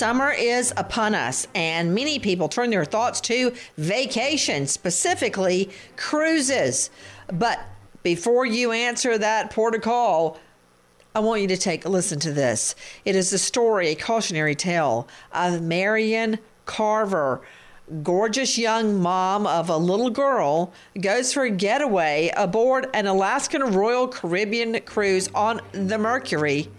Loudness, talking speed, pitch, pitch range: -22 LUFS, 135 wpm, 210 Hz, 175-235 Hz